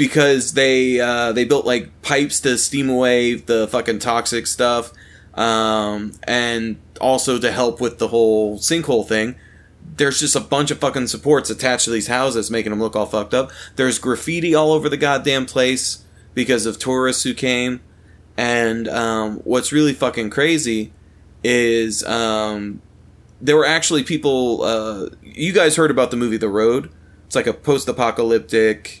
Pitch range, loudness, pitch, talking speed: 110-130 Hz, -18 LUFS, 120 Hz, 160 wpm